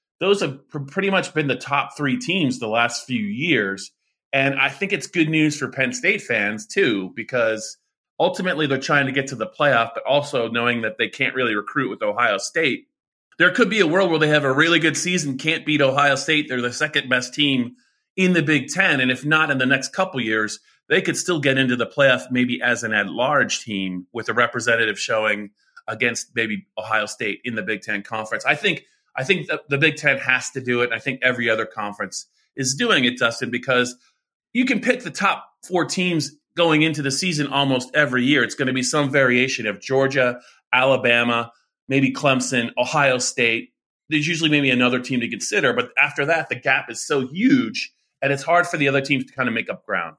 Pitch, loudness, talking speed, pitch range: 135 Hz, -20 LUFS, 215 wpm, 125-155 Hz